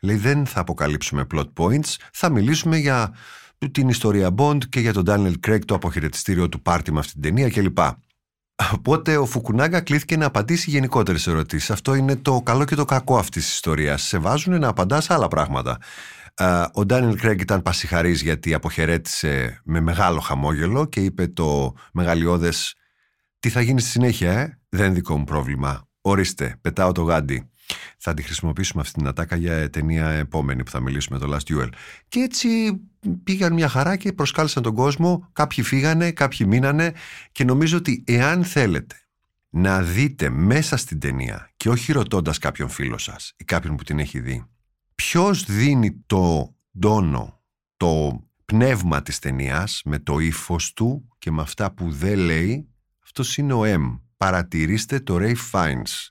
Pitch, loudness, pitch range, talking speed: 95 Hz, -21 LUFS, 80-135 Hz, 165 wpm